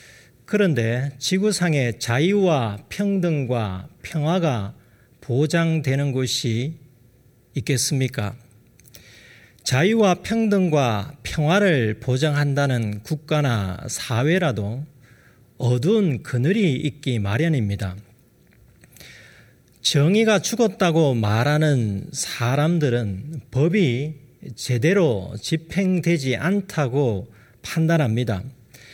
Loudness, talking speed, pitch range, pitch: -21 LUFS, 190 characters per minute, 120-160 Hz, 135 Hz